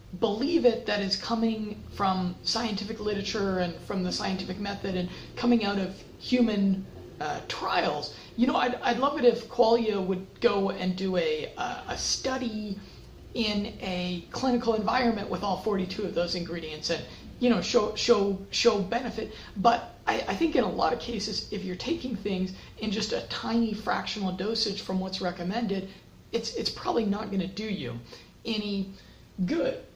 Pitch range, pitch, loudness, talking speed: 190-235 Hz, 205 Hz, -29 LUFS, 170 wpm